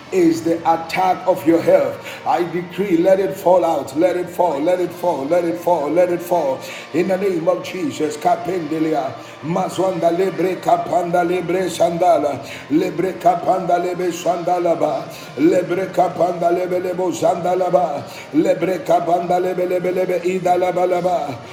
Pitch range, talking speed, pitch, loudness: 175-185 Hz, 135 wpm, 180 Hz, -18 LUFS